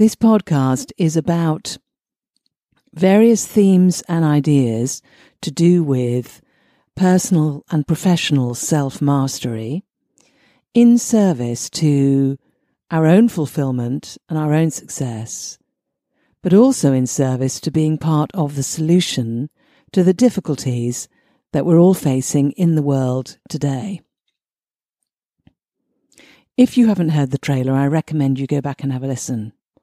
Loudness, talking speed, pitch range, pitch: -17 LUFS, 125 wpm, 135-185 Hz, 155 Hz